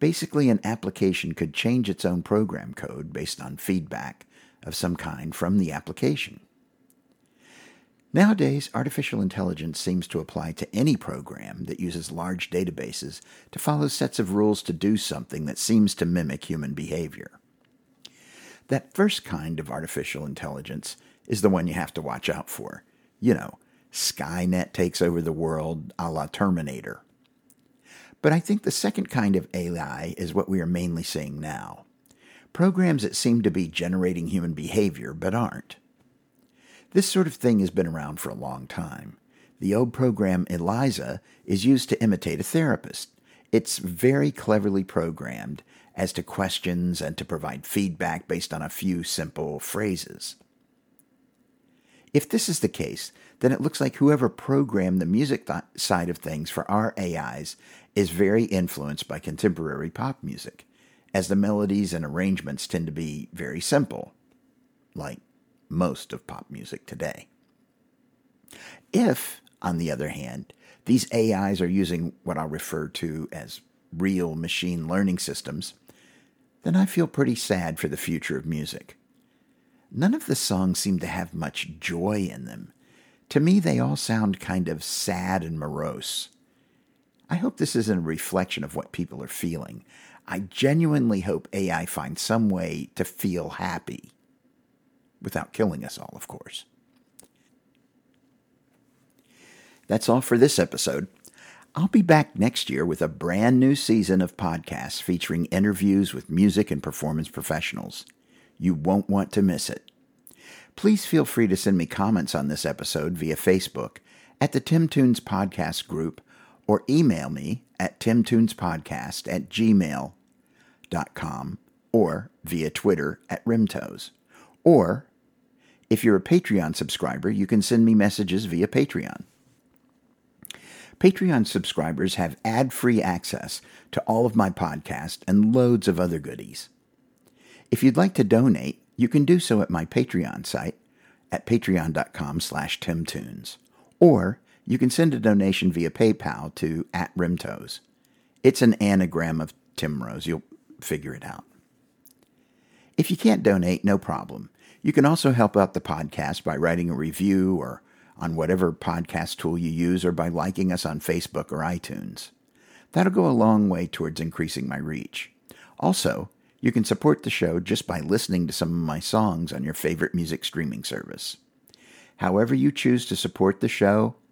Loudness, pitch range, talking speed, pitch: -25 LUFS, 85-130 Hz, 155 wpm, 100 Hz